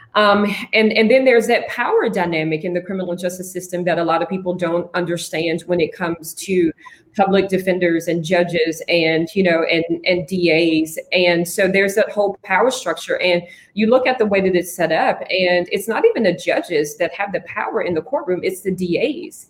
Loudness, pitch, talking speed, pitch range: -18 LUFS, 180 Hz, 205 wpm, 170-200 Hz